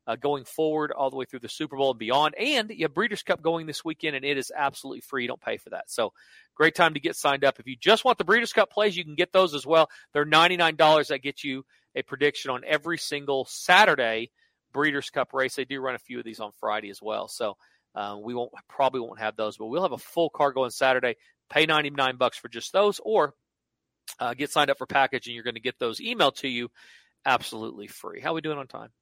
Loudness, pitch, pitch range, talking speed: -25 LUFS, 140 Hz, 125-155 Hz, 255 wpm